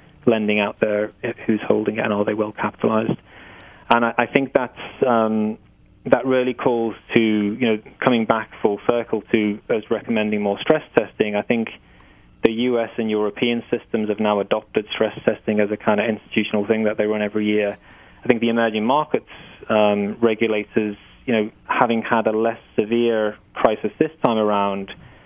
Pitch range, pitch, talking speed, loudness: 105-115 Hz, 110 Hz, 175 wpm, -21 LUFS